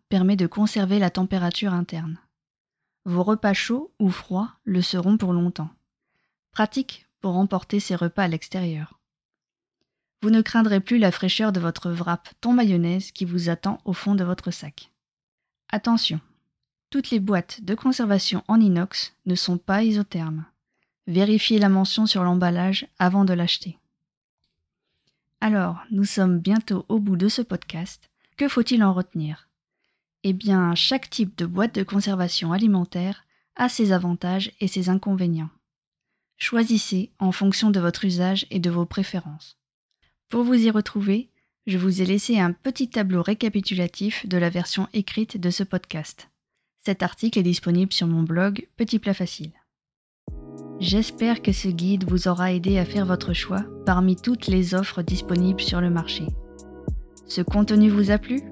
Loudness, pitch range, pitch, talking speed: -23 LUFS, 180-210 Hz, 190 Hz, 155 wpm